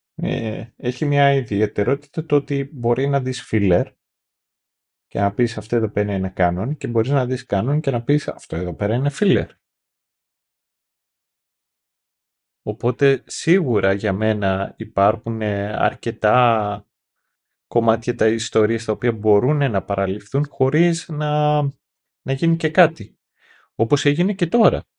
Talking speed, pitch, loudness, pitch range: 130 wpm, 120 Hz, -20 LUFS, 105-145 Hz